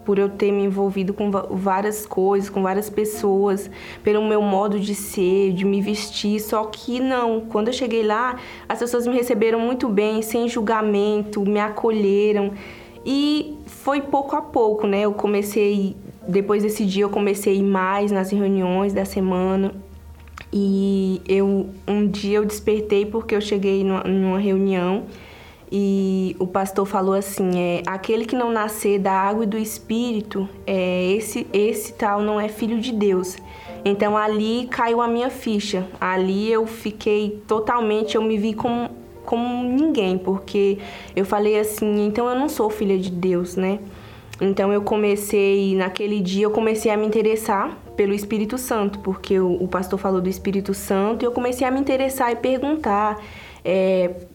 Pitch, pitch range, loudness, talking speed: 205 Hz, 195-220 Hz, -21 LUFS, 165 wpm